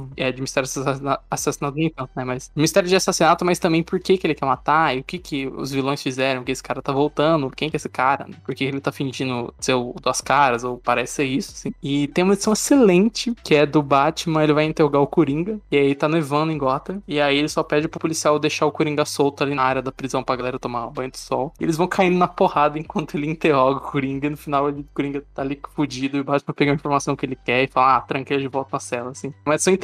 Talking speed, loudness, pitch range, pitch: 255 wpm, -21 LUFS, 135-160 Hz, 145 Hz